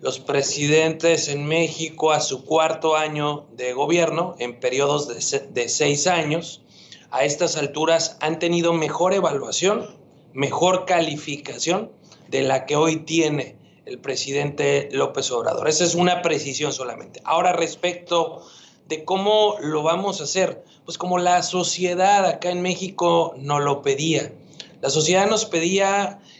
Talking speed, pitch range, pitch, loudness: 140 wpm, 145-180 Hz, 160 Hz, -21 LUFS